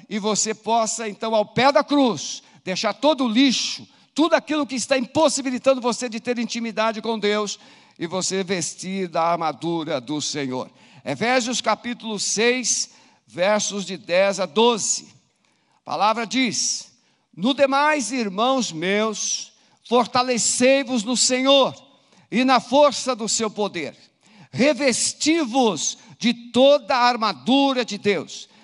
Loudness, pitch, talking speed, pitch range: -21 LUFS, 235 Hz, 130 wpm, 210-260 Hz